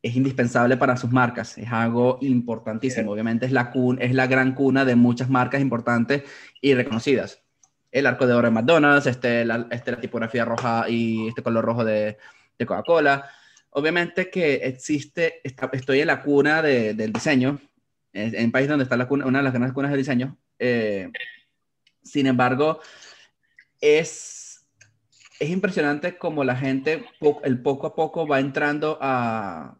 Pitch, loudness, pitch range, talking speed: 130 Hz, -22 LUFS, 120-140 Hz, 165 wpm